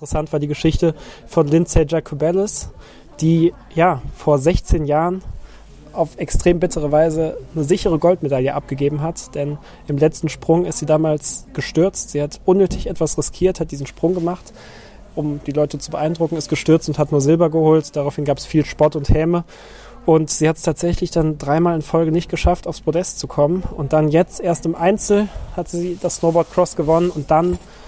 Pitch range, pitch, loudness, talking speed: 150-170 Hz, 160 Hz, -18 LUFS, 185 wpm